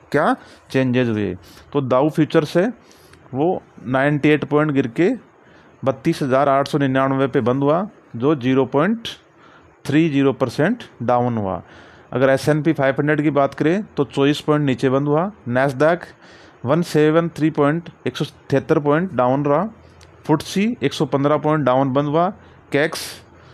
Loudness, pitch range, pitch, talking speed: -19 LUFS, 130-155 Hz, 145 Hz, 165 wpm